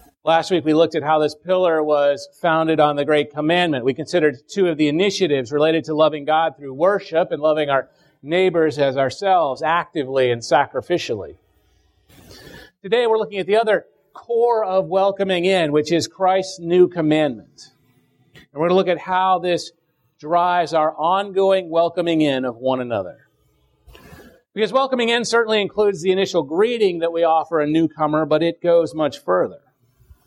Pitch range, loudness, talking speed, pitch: 150-185 Hz, -19 LUFS, 165 wpm, 165 Hz